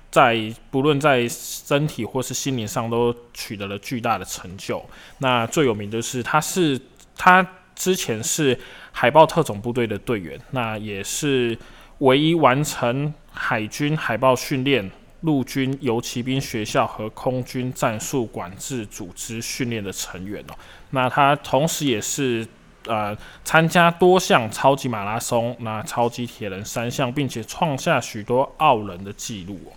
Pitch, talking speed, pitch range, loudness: 125 Hz, 225 characters per minute, 115-140 Hz, -21 LUFS